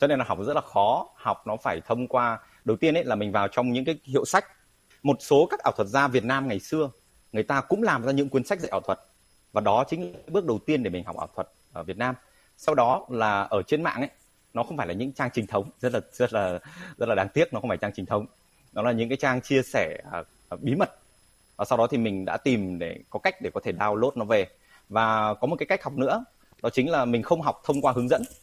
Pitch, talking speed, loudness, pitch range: 125 Hz, 275 wpm, -26 LUFS, 110-140 Hz